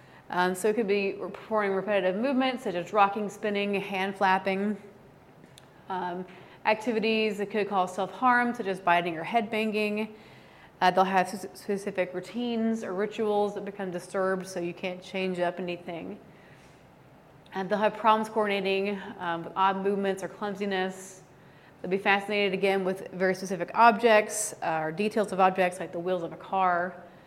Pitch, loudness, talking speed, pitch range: 195 Hz, -28 LUFS, 160 wpm, 185-210 Hz